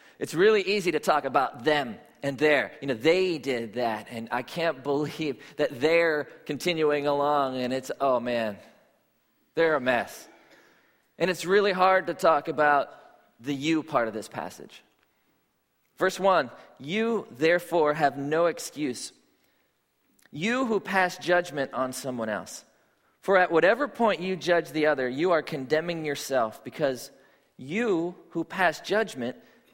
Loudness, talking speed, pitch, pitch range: -26 LUFS, 145 wpm, 155 Hz, 140-175 Hz